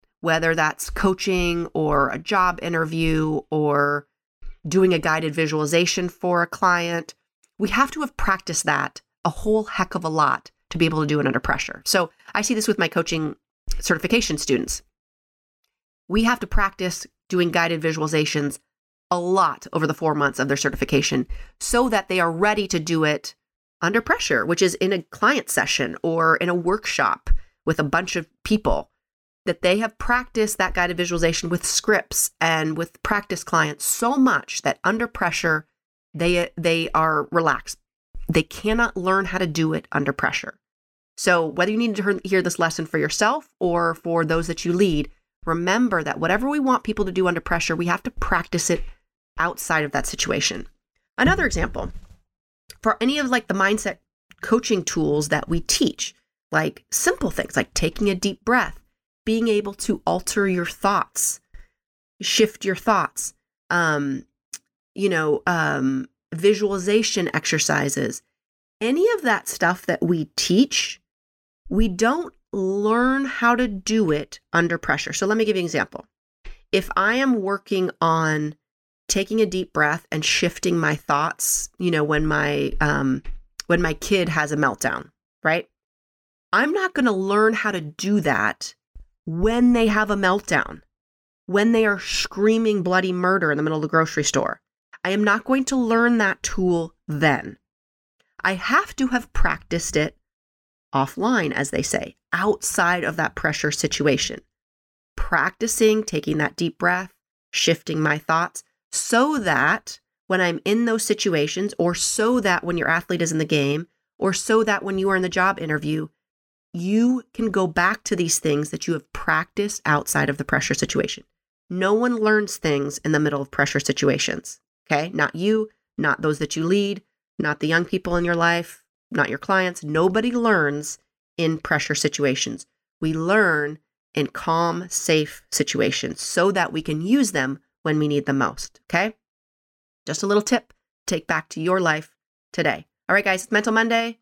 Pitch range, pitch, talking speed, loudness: 155-210 Hz, 175 Hz, 170 wpm, -22 LUFS